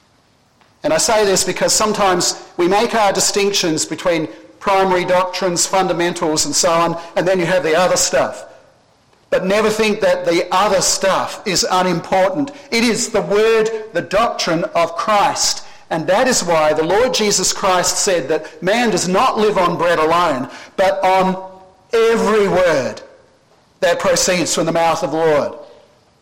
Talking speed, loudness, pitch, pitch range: 160 wpm, -15 LUFS, 190 Hz, 175-210 Hz